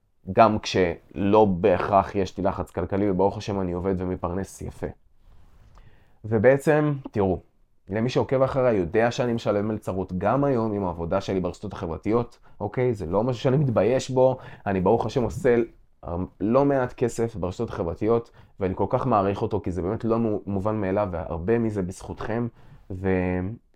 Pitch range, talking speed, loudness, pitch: 95-120 Hz, 150 wpm, -24 LUFS, 105 Hz